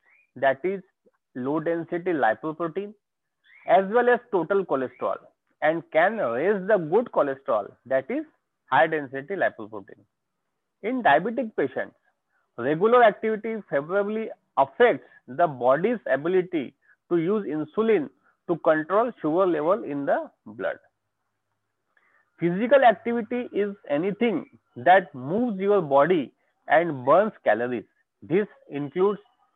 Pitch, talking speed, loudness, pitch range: 195 Hz, 105 wpm, -24 LUFS, 155-225 Hz